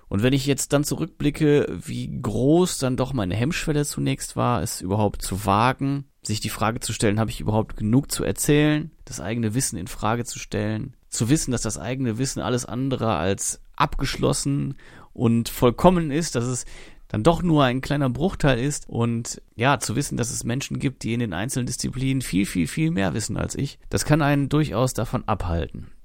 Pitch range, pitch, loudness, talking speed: 105-140 Hz, 125 Hz, -23 LUFS, 195 wpm